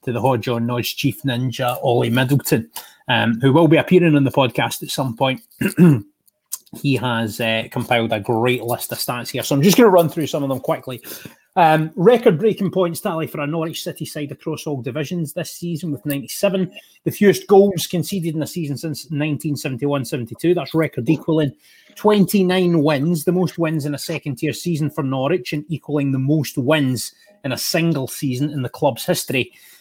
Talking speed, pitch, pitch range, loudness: 190 wpm, 150 Hz, 135-170 Hz, -19 LUFS